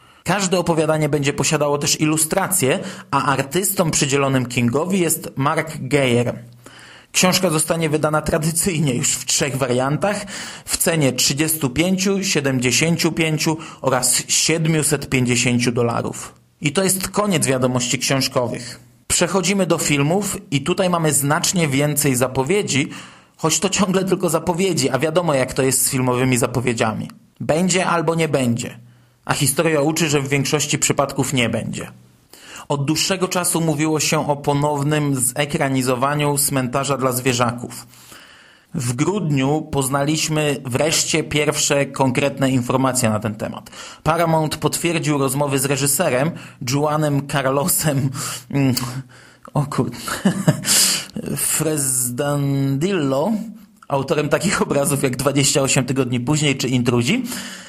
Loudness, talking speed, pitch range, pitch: -18 LUFS, 110 wpm, 130-165 Hz, 145 Hz